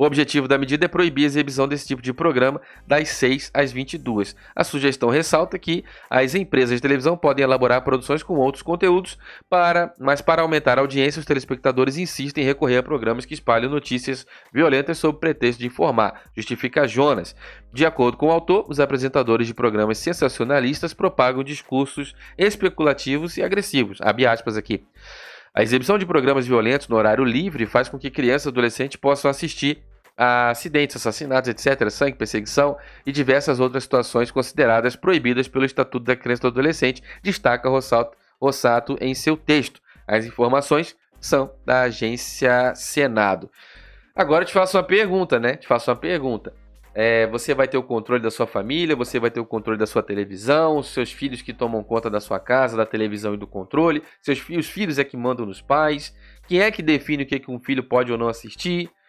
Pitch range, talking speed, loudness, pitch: 120-150 Hz, 185 wpm, -21 LUFS, 135 Hz